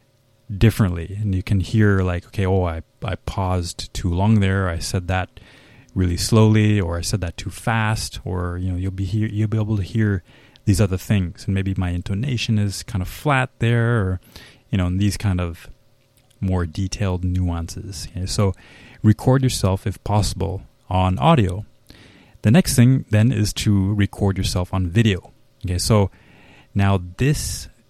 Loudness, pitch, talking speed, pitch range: -21 LUFS, 100 Hz, 170 wpm, 95-110 Hz